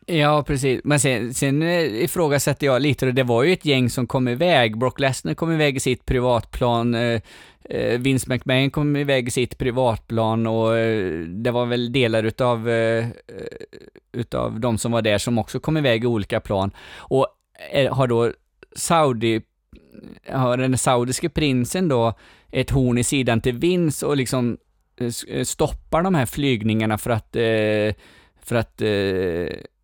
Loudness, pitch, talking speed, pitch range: -21 LUFS, 125 Hz, 145 wpm, 115-140 Hz